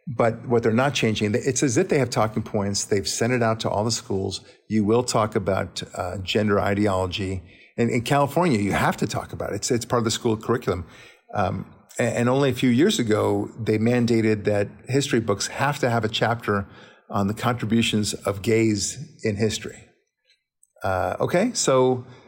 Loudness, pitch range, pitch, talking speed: -23 LUFS, 105-125 Hz, 115 Hz, 195 wpm